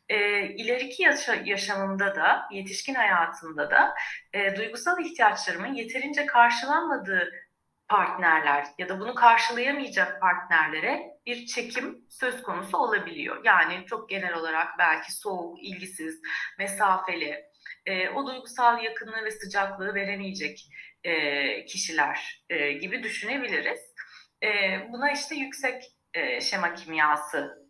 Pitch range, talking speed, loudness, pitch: 190-260 Hz, 95 wpm, -26 LUFS, 210 Hz